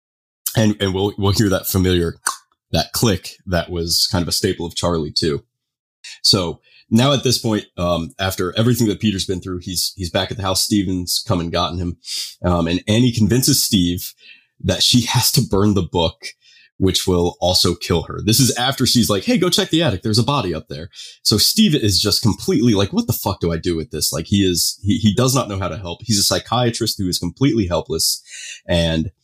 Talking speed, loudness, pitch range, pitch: 220 wpm, -17 LUFS, 90-115 Hz, 100 Hz